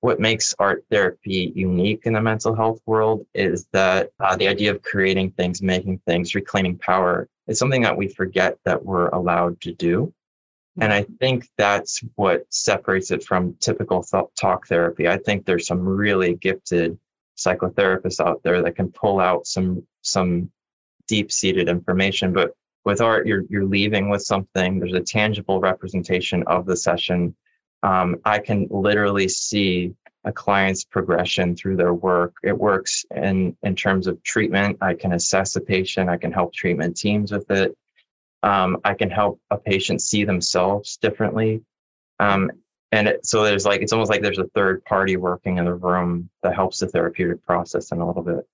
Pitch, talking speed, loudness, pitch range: 95 Hz, 175 wpm, -21 LUFS, 90-105 Hz